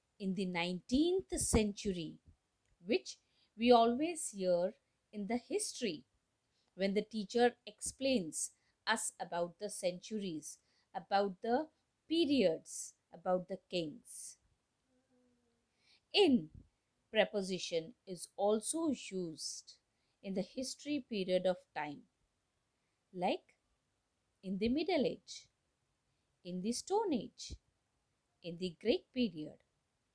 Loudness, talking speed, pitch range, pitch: -37 LUFS, 100 wpm, 180-250 Hz, 205 Hz